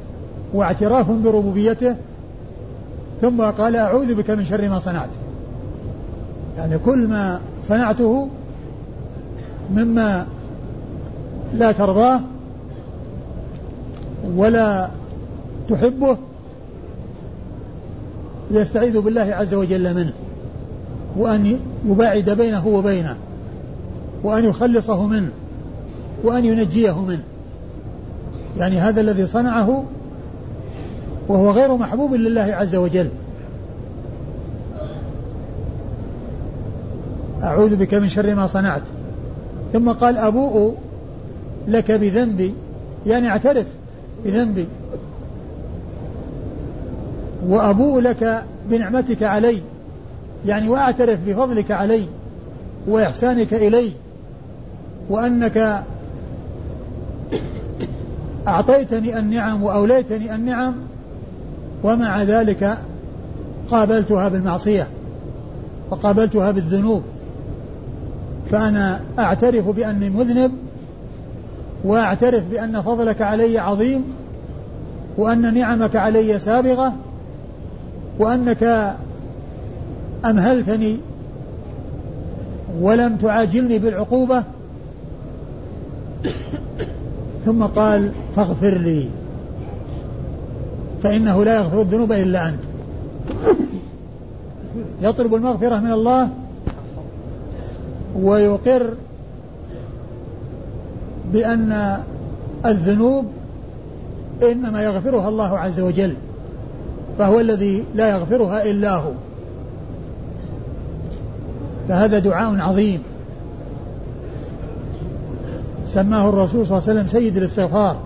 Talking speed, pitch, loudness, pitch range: 70 wpm, 210 Hz, -18 LUFS, 190-230 Hz